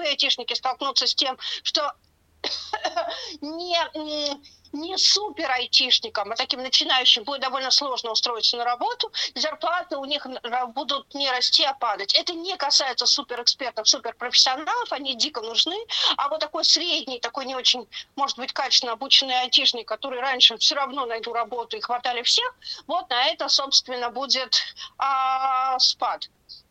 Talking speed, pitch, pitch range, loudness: 140 wpm, 270 Hz, 250-310 Hz, -22 LUFS